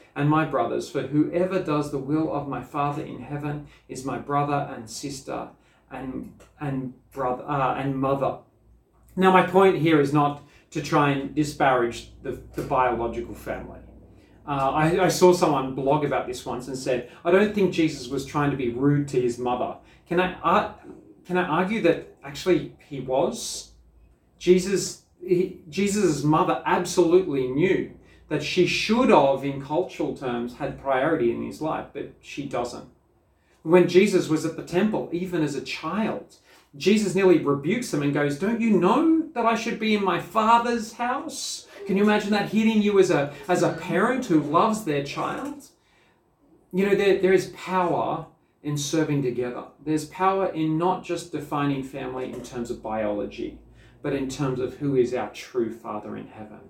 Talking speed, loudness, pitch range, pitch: 175 wpm, -24 LUFS, 135-185 Hz, 155 Hz